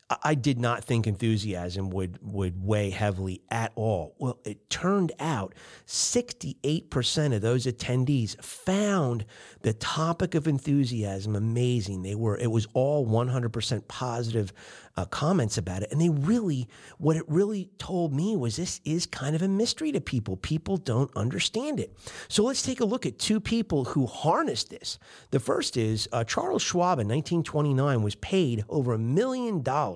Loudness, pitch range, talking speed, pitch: -28 LUFS, 110-165 Hz, 170 wpm, 130 Hz